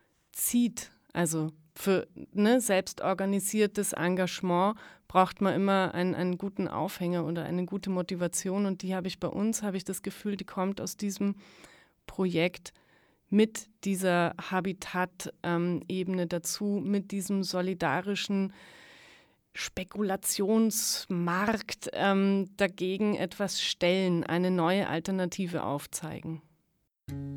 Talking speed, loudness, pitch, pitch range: 105 wpm, -30 LUFS, 185 Hz, 175-200 Hz